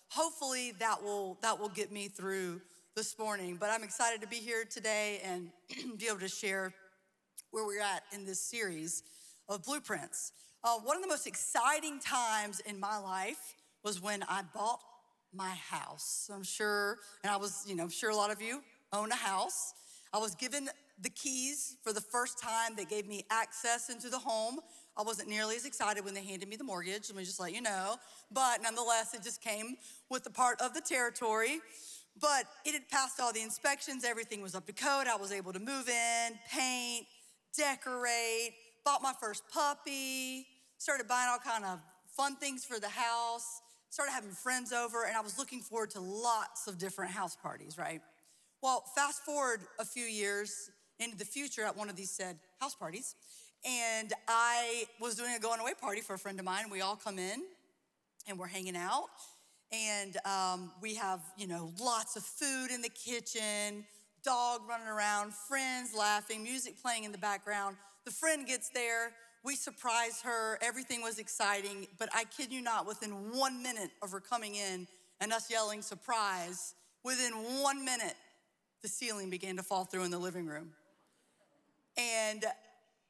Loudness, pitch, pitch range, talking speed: -37 LUFS, 225 Hz, 200-250 Hz, 185 wpm